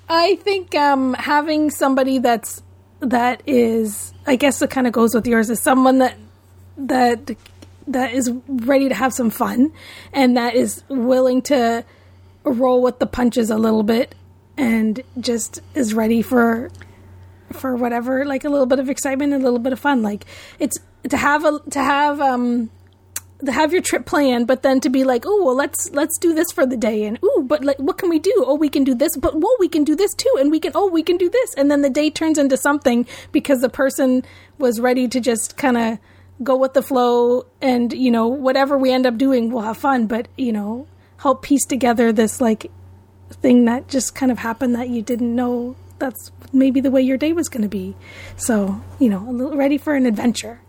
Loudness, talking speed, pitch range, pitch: -18 LUFS, 210 wpm, 235-280 Hz, 255 Hz